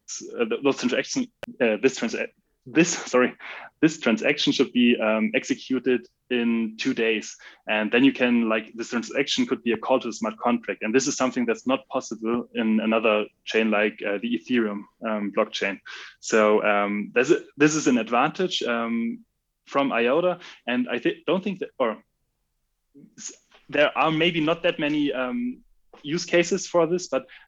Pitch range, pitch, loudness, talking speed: 110-155 Hz, 125 Hz, -24 LUFS, 170 wpm